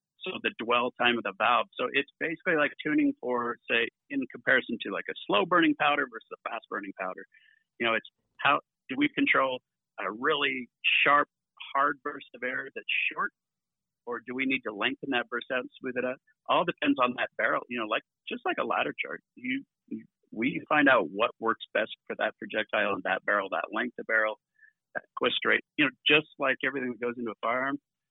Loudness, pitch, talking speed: -28 LUFS, 145 Hz, 215 wpm